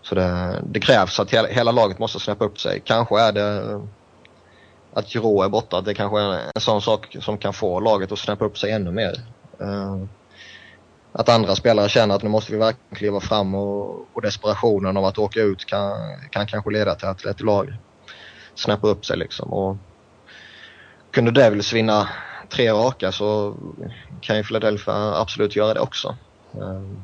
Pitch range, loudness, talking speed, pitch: 95-105 Hz, -21 LUFS, 175 wpm, 105 Hz